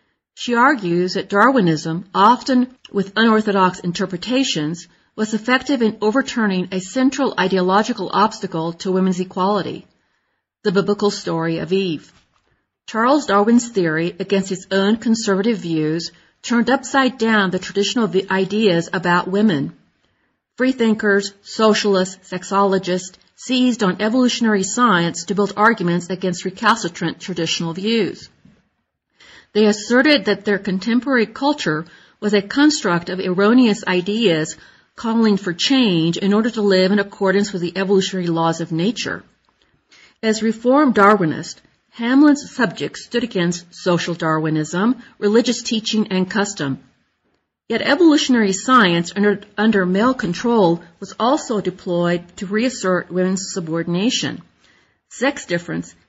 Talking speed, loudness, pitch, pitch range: 120 wpm, -18 LUFS, 200 Hz, 180-230 Hz